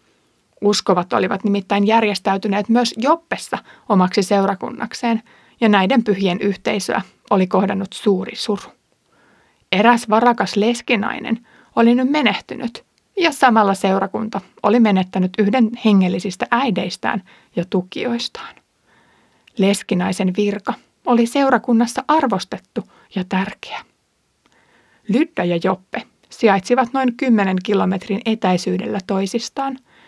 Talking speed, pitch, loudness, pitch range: 95 wpm, 210 Hz, -18 LUFS, 195-240 Hz